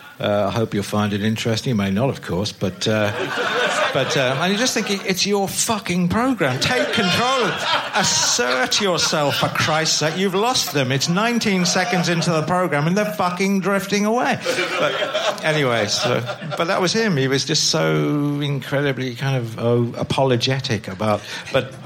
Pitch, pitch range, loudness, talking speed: 150 Hz, 120-195 Hz, -19 LUFS, 175 wpm